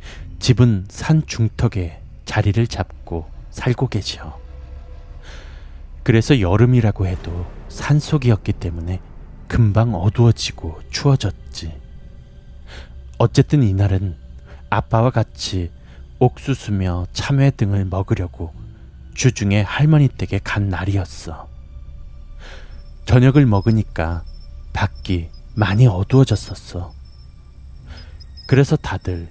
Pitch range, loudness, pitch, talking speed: 70-115 Hz, -18 LUFS, 90 Hz, 210 characters per minute